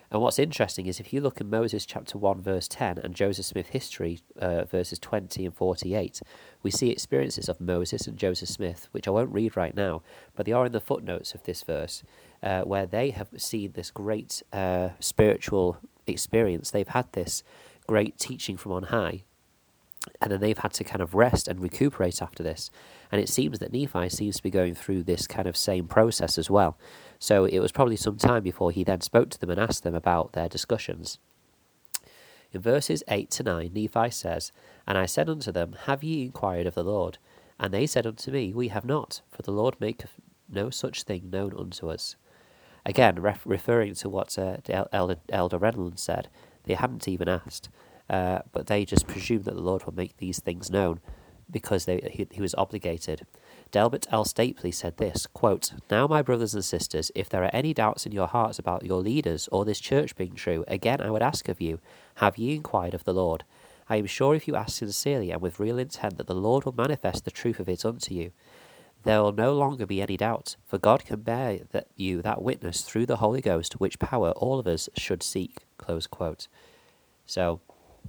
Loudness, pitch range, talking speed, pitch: -28 LUFS, 90-110 Hz, 205 wpm, 100 Hz